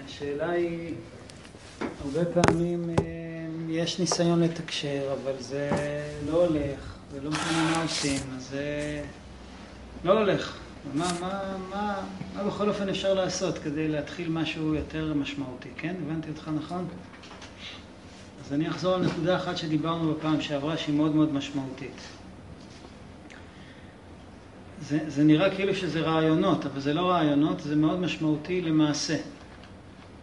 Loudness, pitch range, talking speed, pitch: -28 LUFS, 135-165 Hz, 125 wpm, 150 Hz